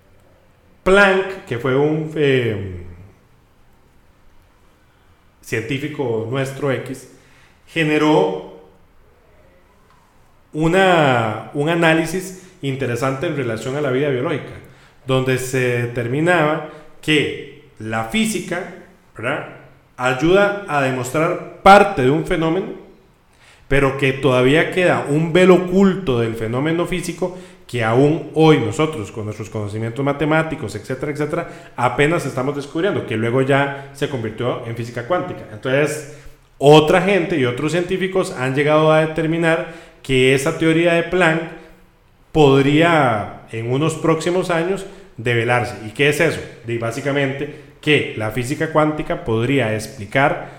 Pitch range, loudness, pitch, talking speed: 120-165 Hz, -18 LUFS, 145 Hz, 115 wpm